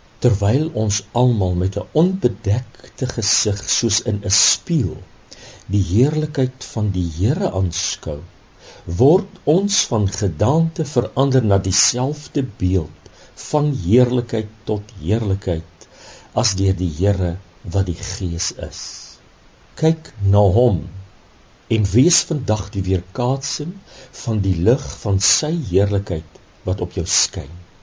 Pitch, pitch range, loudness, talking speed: 105 Hz, 95-130 Hz, -19 LUFS, 120 wpm